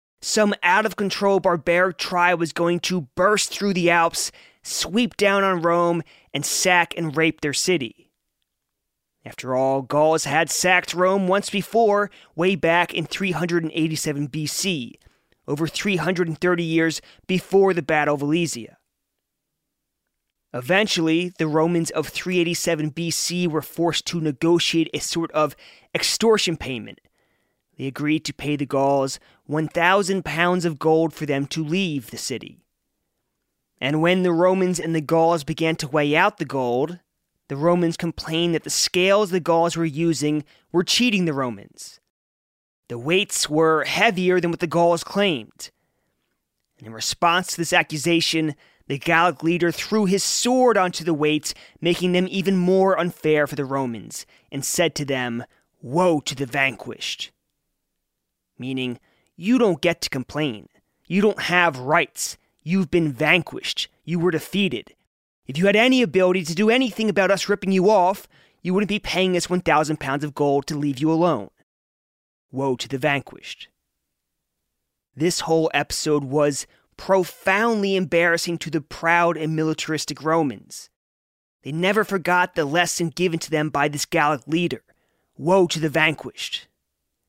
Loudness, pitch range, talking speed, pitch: -21 LUFS, 150-180 Hz, 150 wpm, 165 Hz